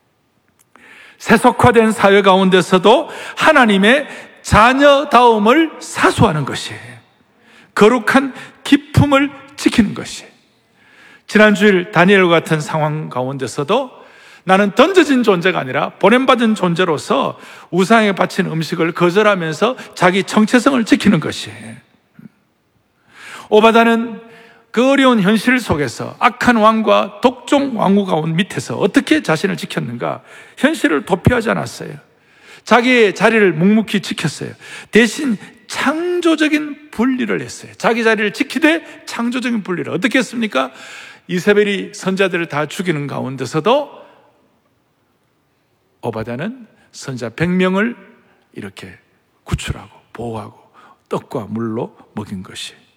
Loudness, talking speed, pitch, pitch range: -14 LUFS, 265 characters per minute, 215 Hz, 180-250 Hz